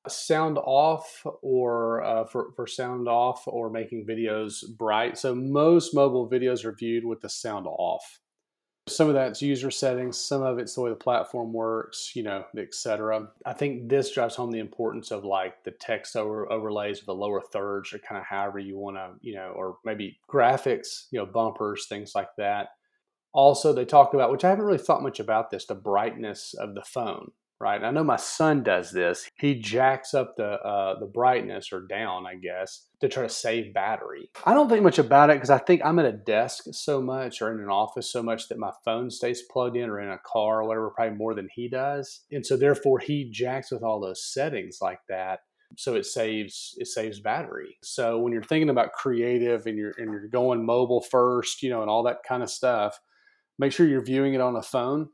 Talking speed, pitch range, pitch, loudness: 215 wpm, 110-140 Hz, 120 Hz, -26 LUFS